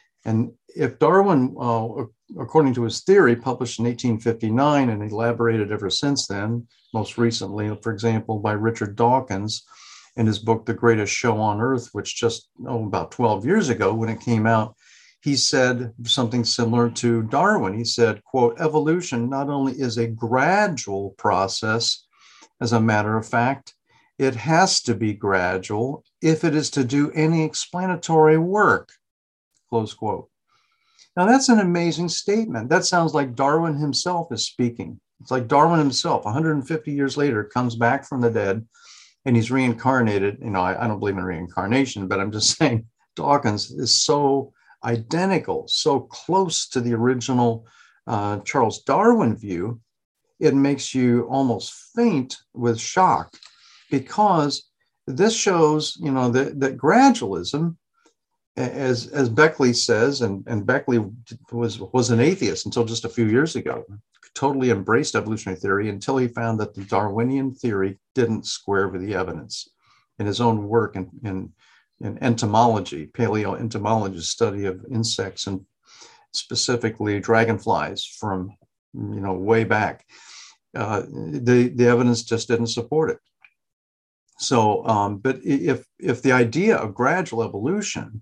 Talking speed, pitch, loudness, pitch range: 145 wpm, 120 Hz, -21 LUFS, 110-140 Hz